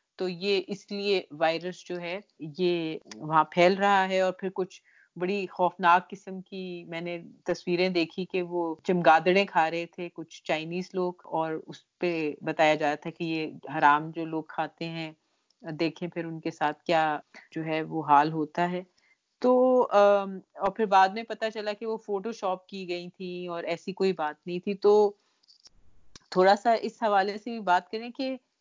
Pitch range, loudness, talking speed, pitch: 165-200 Hz, -27 LUFS, 185 wpm, 180 Hz